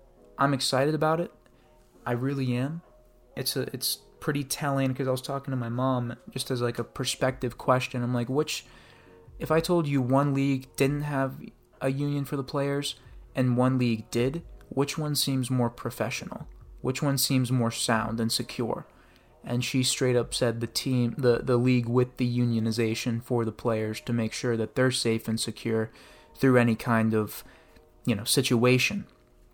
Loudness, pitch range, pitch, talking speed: -27 LUFS, 115-135 Hz, 125 Hz, 180 wpm